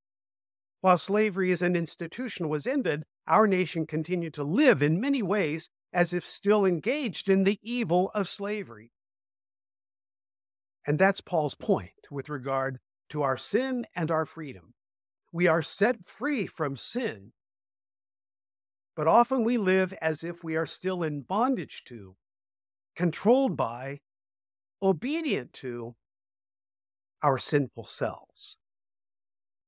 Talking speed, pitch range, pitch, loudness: 125 wpm, 155-255 Hz, 185 Hz, -28 LUFS